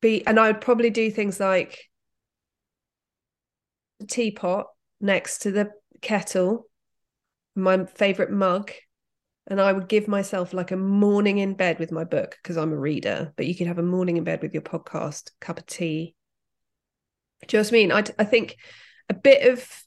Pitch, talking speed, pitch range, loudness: 200 Hz, 180 wpm, 185-220 Hz, -23 LUFS